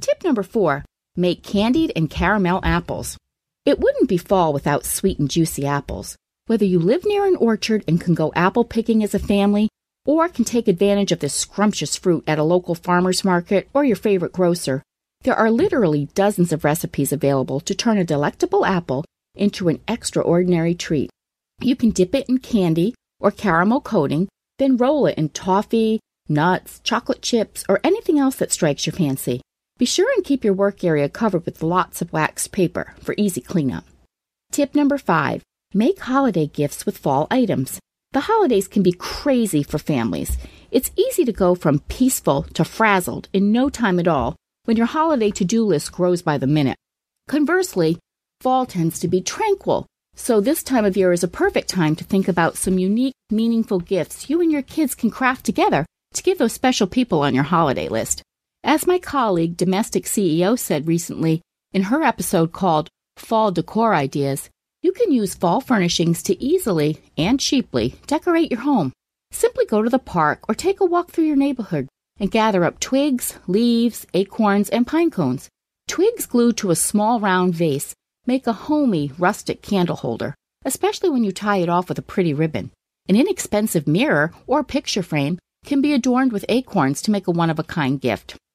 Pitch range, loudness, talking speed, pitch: 165-255 Hz, -20 LUFS, 185 wpm, 200 Hz